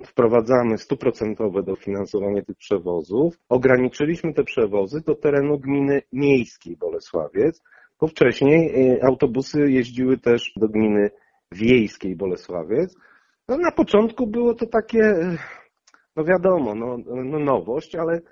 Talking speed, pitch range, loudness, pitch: 110 wpm, 120-165 Hz, -21 LUFS, 135 Hz